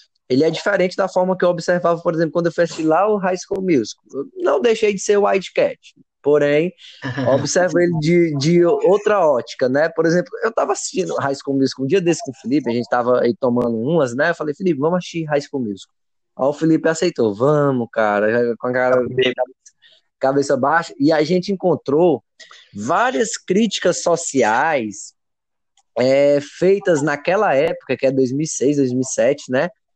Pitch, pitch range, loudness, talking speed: 160 Hz, 135-180 Hz, -18 LUFS, 180 wpm